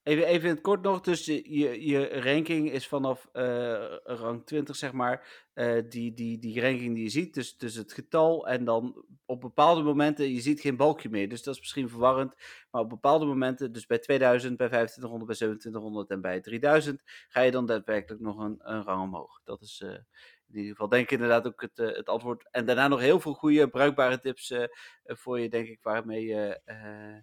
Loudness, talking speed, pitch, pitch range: -28 LUFS, 215 wpm, 125 Hz, 115-140 Hz